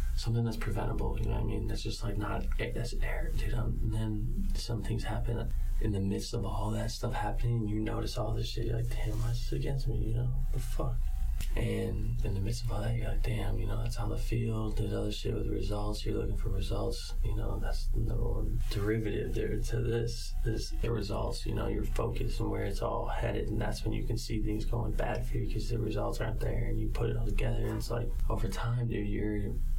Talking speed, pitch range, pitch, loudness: 245 wpm, 105-115 Hz, 110 Hz, -35 LUFS